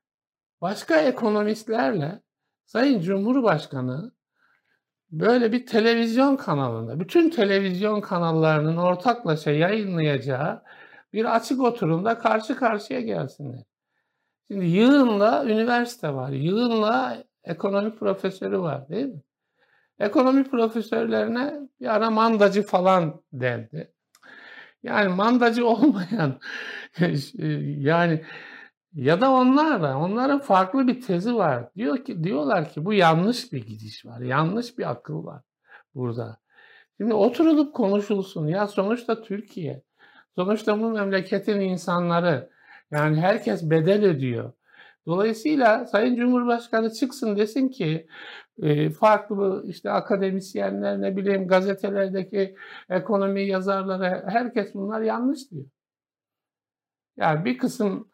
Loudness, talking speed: -23 LUFS, 100 wpm